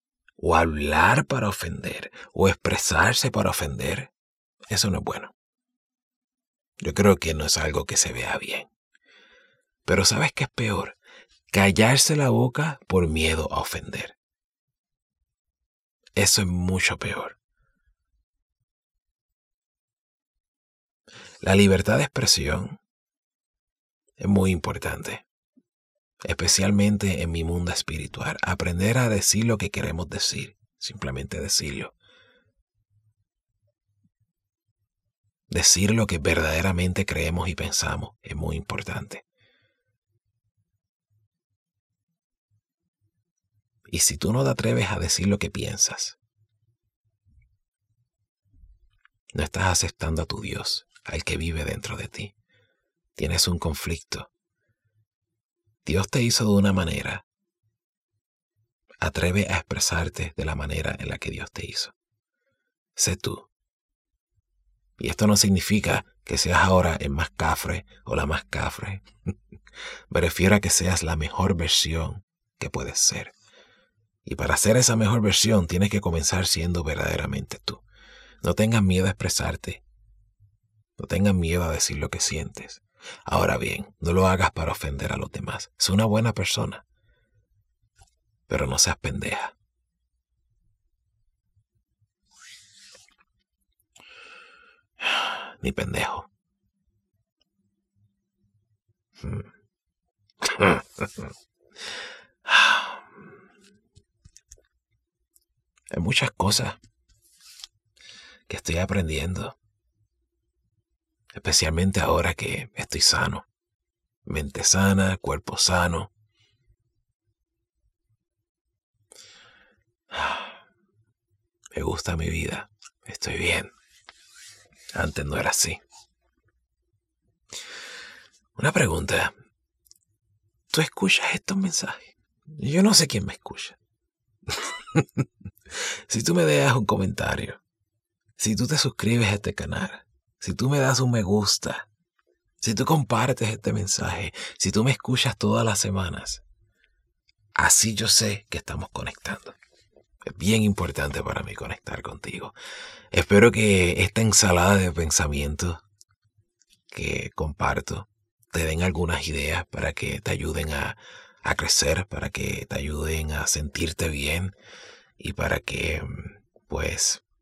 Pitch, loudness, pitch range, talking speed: 100 Hz, -23 LUFS, 85-110 Hz, 105 wpm